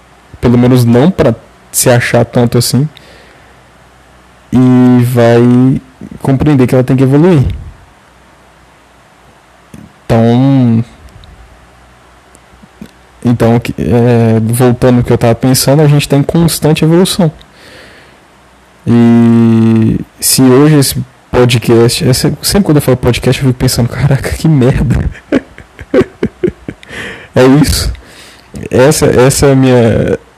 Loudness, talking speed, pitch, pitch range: -8 LUFS, 110 wpm, 125 Hz, 115-135 Hz